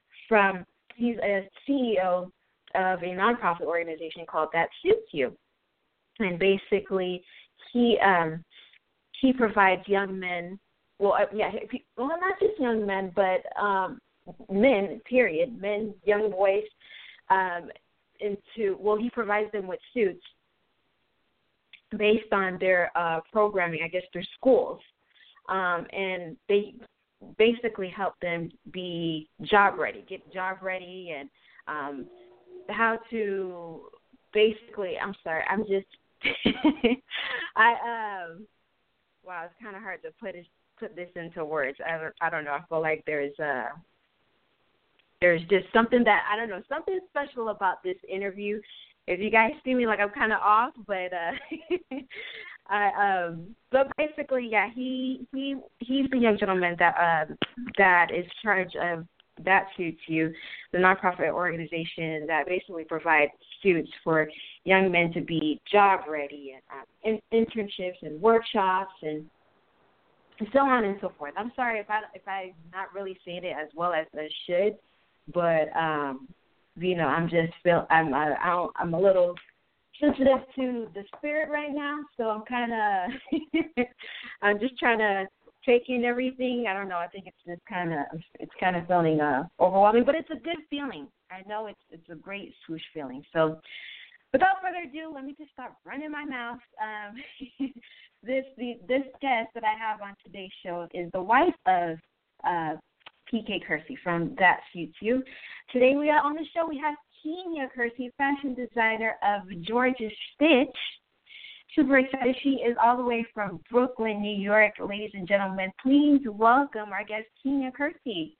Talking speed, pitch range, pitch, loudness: 155 wpm, 180-250 Hz, 205 Hz, -27 LUFS